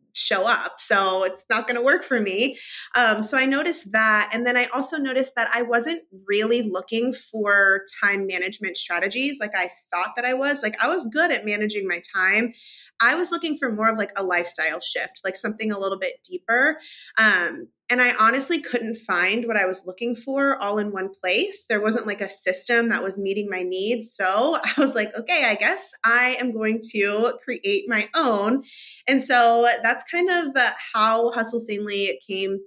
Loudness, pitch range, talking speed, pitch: -22 LUFS, 200-250 Hz, 195 wpm, 225 Hz